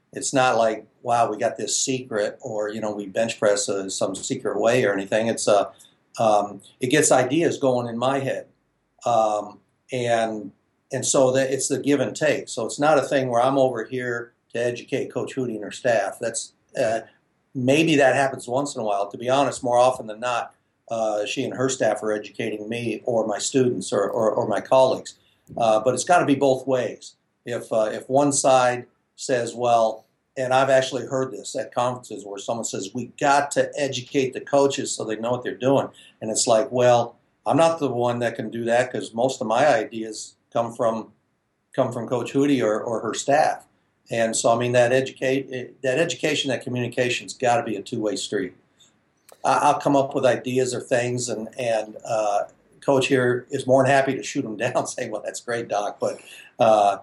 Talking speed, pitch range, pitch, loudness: 205 wpm, 110-130 Hz, 125 Hz, -23 LUFS